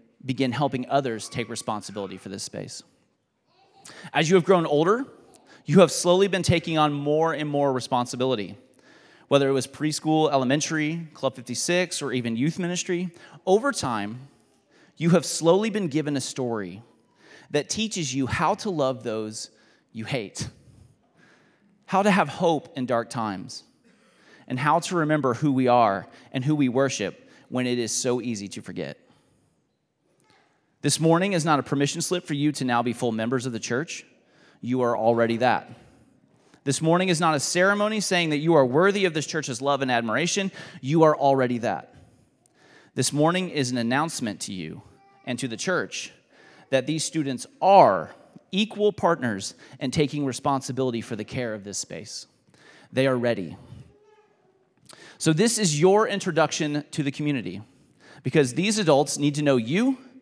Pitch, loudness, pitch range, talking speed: 145 Hz, -24 LUFS, 125-170 Hz, 160 wpm